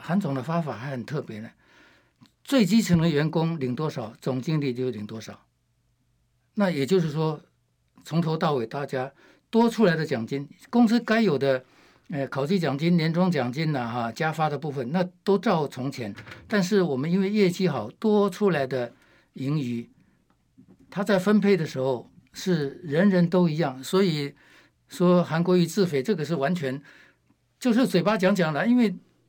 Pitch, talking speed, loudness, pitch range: 160 Hz, 245 characters per minute, -25 LUFS, 130-190 Hz